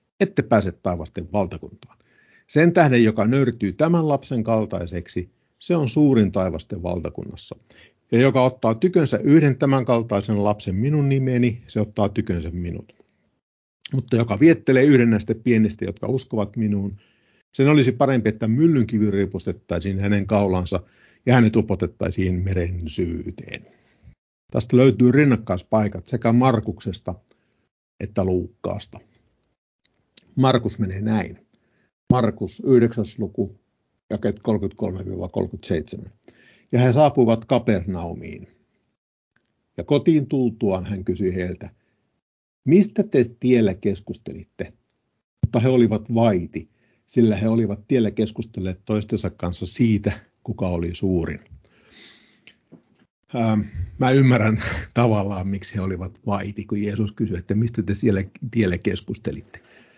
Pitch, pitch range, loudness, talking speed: 110 Hz, 95-125 Hz, -21 LUFS, 110 wpm